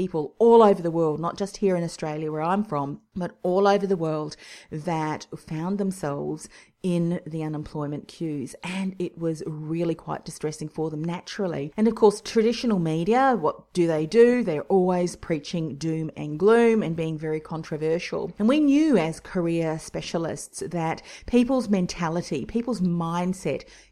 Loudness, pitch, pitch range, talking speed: -25 LUFS, 170 Hz, 160-200 Hz, 160 wpm